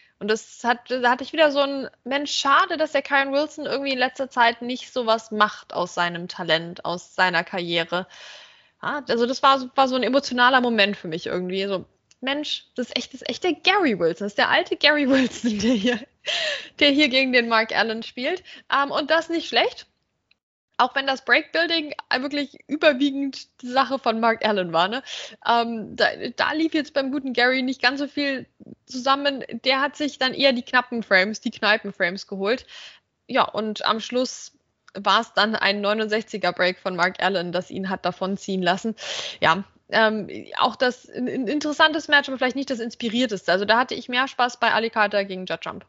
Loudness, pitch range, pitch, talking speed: -22 LUFS, 205-275 Hz, 245 Hz, 200 wpm